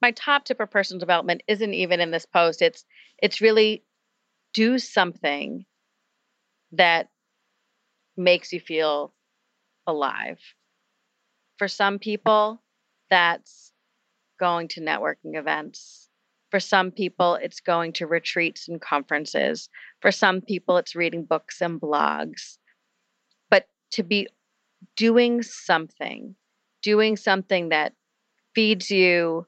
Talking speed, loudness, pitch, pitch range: 115 wpm, -23 LUFS, 190 Hz, 170-220 Hz